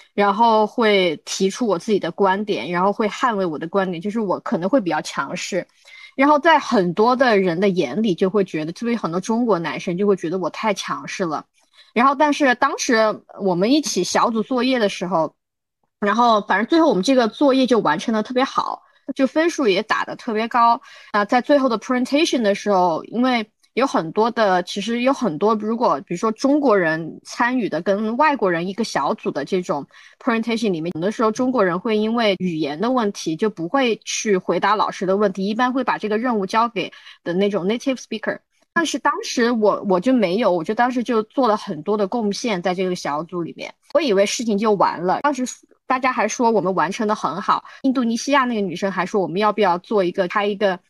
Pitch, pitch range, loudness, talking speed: 215 Hz, 195-255 Hz, -20 LUFS, 350 characters per minute